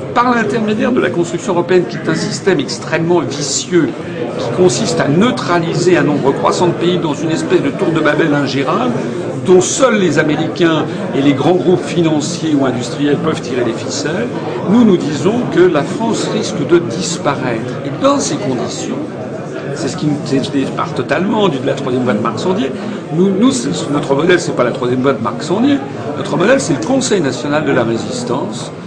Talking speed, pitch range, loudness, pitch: 185 wpm, 140-185 Hz, -14 LUFS, 160 Hz